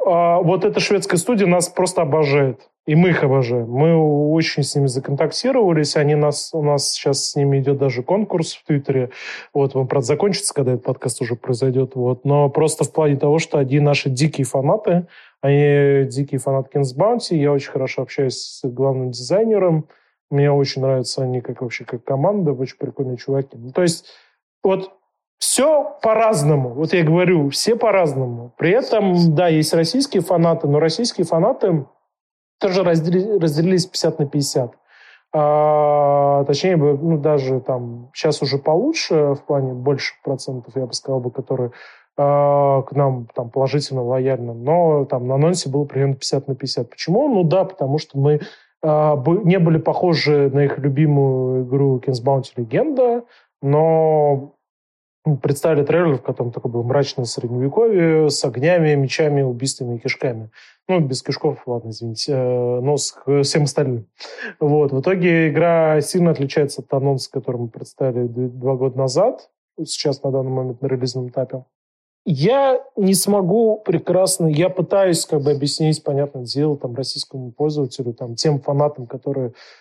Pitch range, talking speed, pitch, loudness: 135-165 Hz, 160 wpm, 145 Hz, -18 LUFS